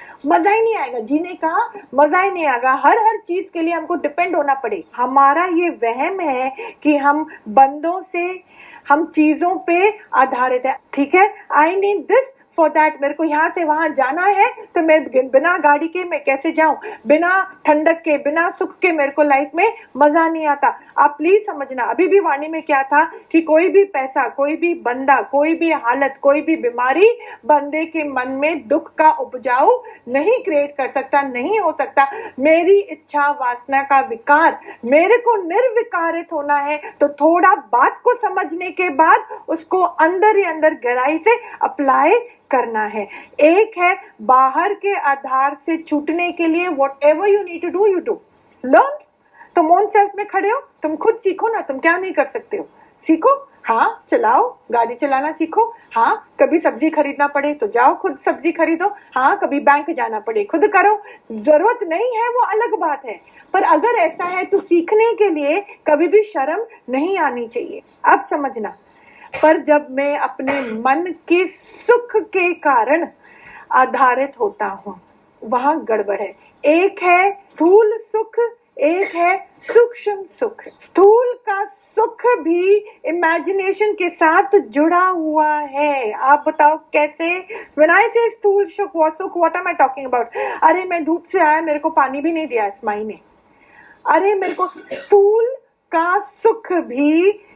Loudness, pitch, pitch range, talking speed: -16 LUFS, 335 Hz, 290-405 Hz, 165 wpm